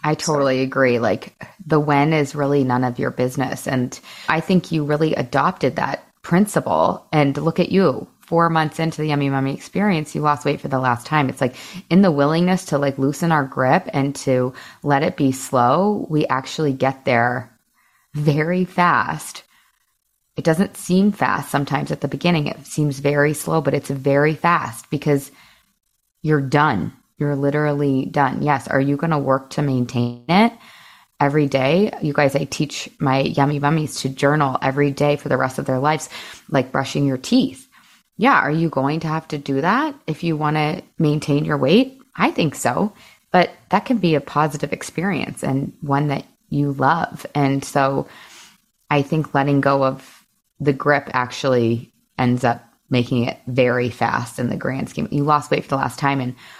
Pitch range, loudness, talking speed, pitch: 135-160 Hz, -19 LUFS, 185 wpm, 145 Hz